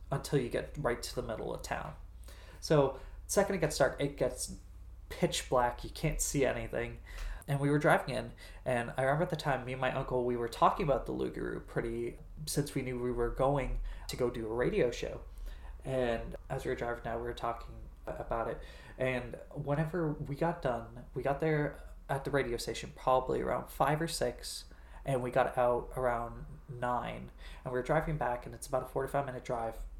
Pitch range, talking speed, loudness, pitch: 115-140 Hz, 205 wpm, -34 LUFS, 125 Hz